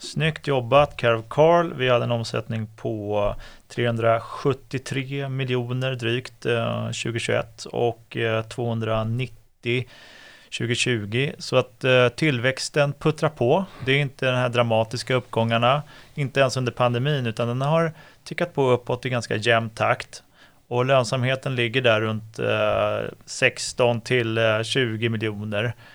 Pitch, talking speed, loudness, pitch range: 125 Hz, 115 wpm, -23 LUFS, 115-135 Hz